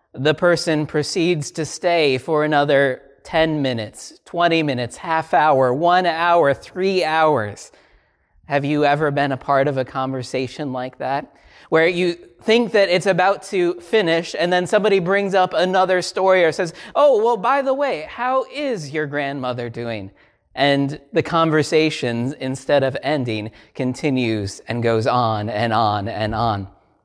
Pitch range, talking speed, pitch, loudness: 130-175 Hz, 155 wpm, 150 Hz, -19 LUFS